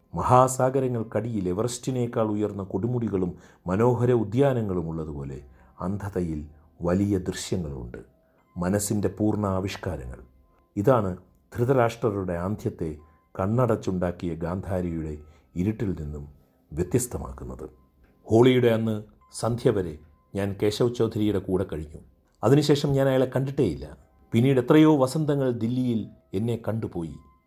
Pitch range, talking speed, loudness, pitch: 80-115 Hz, 85 wpm, -25 LUFS, 95 Hz